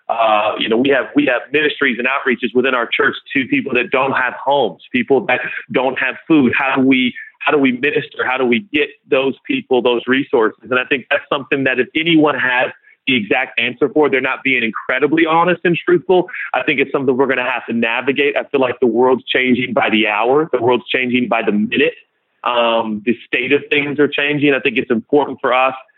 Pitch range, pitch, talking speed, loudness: 125-150 Hz, 135 Hz, 225 wpm, -15 LUFS